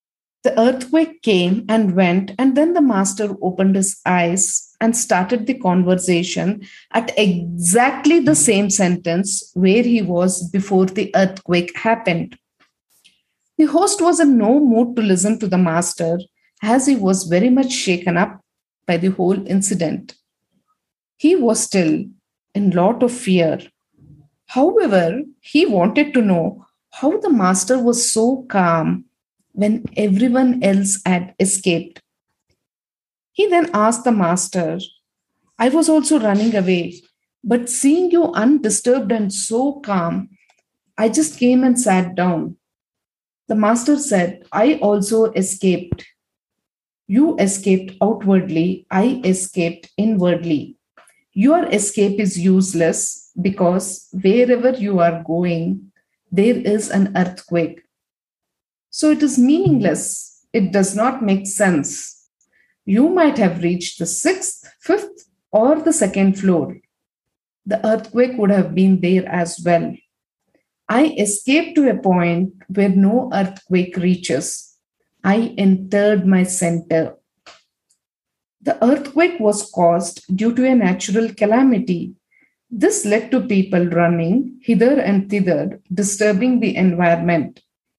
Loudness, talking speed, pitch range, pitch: -17 LUFS, 125 wpm, 185-245 Hz, 200 Hz